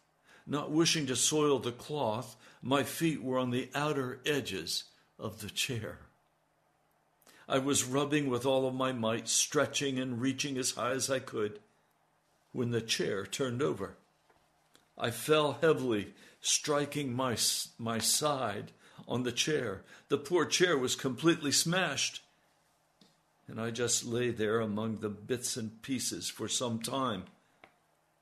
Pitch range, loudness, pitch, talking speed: 120-145 Hz, -32 LUFS, 130 Hz, 140 wpm